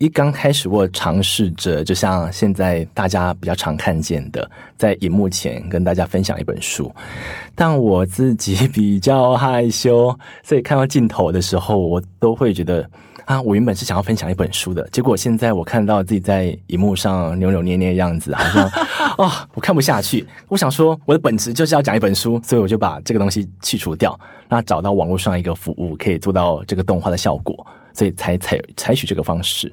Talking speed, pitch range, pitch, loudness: 305 characters per minute, 90-115 Hz, 100 Hz, -17 LUFS